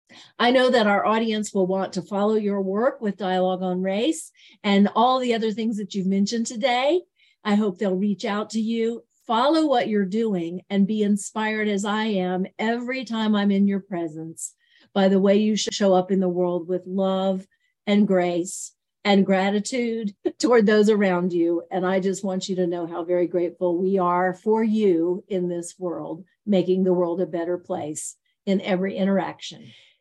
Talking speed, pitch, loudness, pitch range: 185 wpm, 195 Hz, -23 LUFS, 185-220 Hz